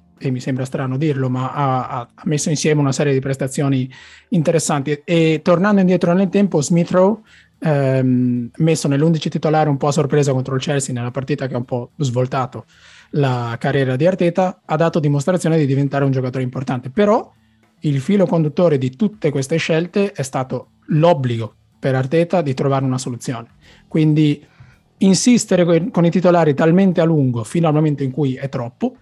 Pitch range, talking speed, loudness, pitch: 130-170 Hz, 170 wpm, -17 LUFS, 145 Hz